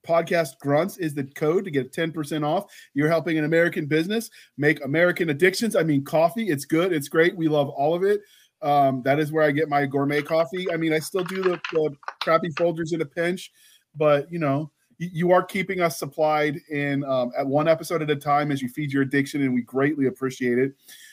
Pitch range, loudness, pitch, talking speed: 145-170 Hz, -23 LUFS, 155 Hz, 220 wpm